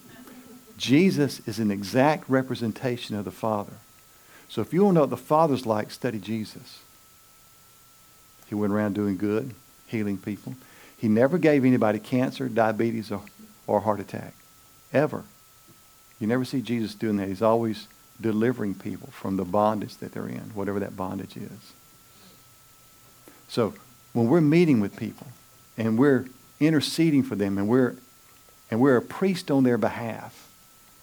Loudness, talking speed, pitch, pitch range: -25 LUFS, 150 wpm, 120 Hz, 105-130 Hz